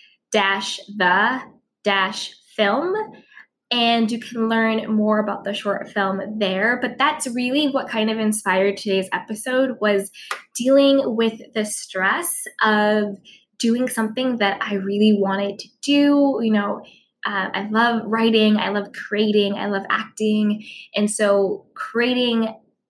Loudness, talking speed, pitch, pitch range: -20 LUFS, 135 wpm, 215 Hz, 200-240 Hz